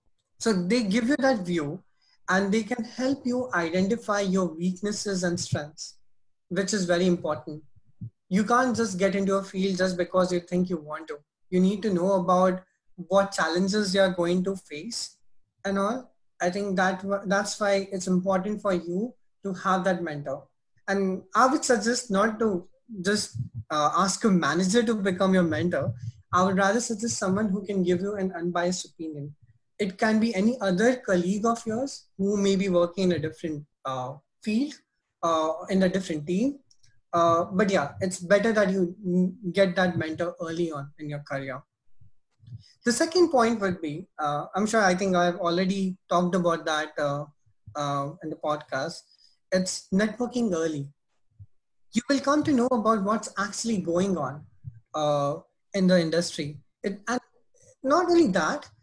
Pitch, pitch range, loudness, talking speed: 185 Hz, 160-205 Hz, -26 LUFS, 170 wpm